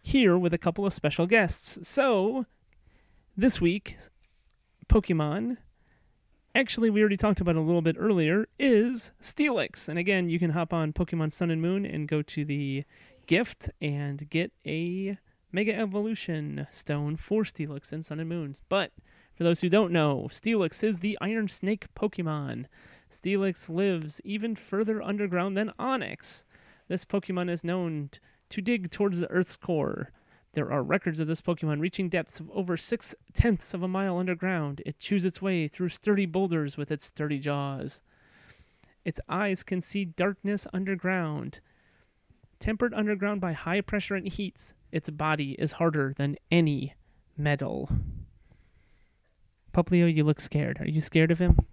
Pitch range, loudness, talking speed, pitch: 155-200 Hz, -28 LUFS, 160 wpm, 175 Hz